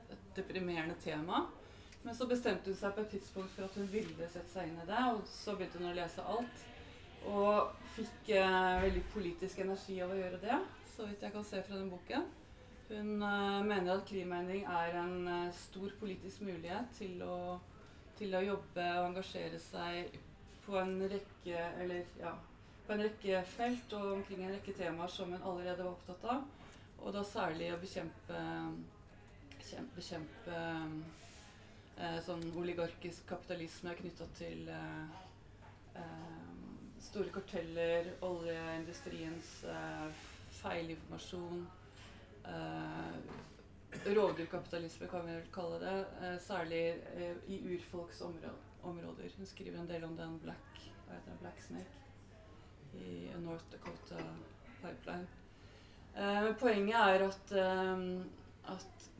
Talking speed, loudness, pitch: 140 wpm, -41 LUFS, 175 Hz